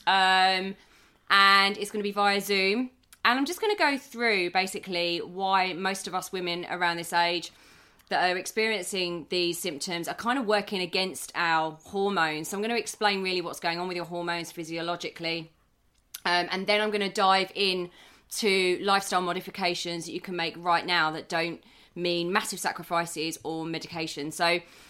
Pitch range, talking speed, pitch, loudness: 170-200 Hz, 180 wpm, 180 Hz, -27 LUFS